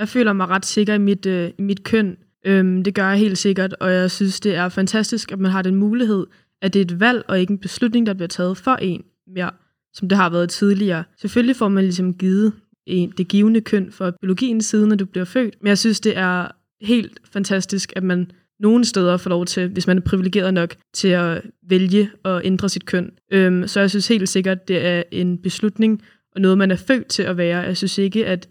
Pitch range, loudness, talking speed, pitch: 185-210 Hz, -19 LUFS, 230 wpm, 190 Hz